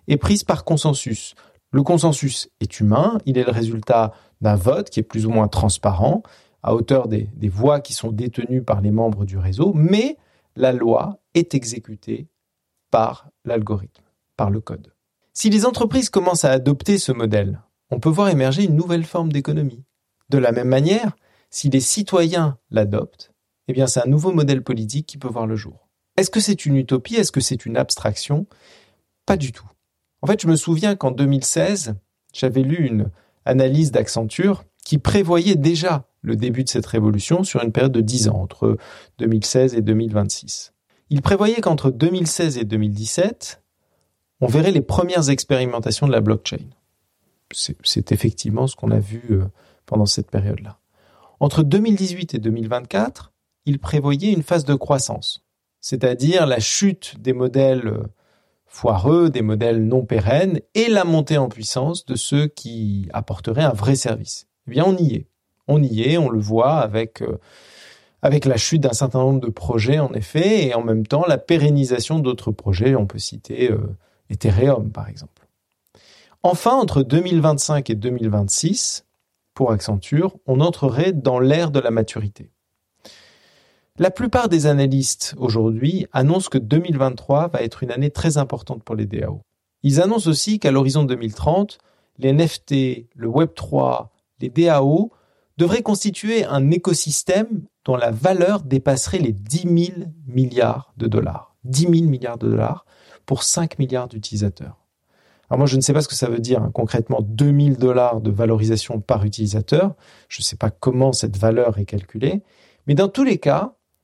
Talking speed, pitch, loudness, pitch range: 165 wpm, 130 Hz, -19 LUFS, 110-160 Hz